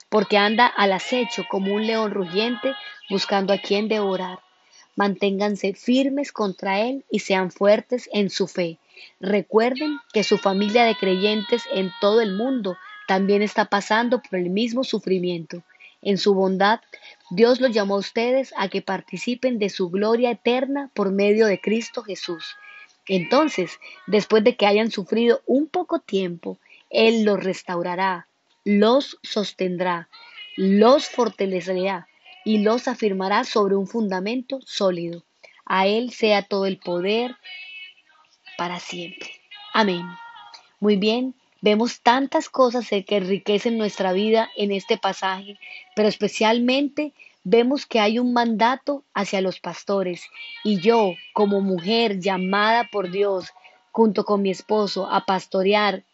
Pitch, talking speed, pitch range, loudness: 210 Hz, 135 wpm, 195-240 Hz, -22 LUFS